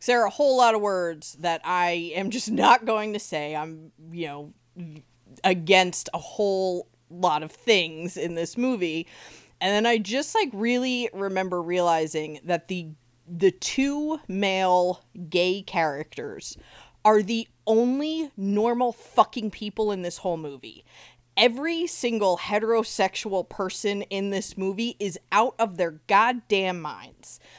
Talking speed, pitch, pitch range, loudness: 145 wpm, 190 Hz, 170-225 Hz, -25 LUFS